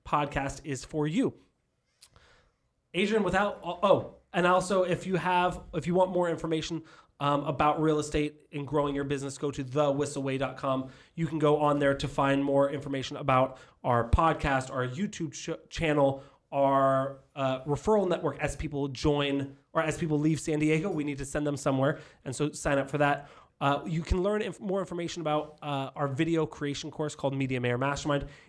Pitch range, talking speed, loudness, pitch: 140-160 Hz, 180 wpm, -29 LUFS, 145 Hz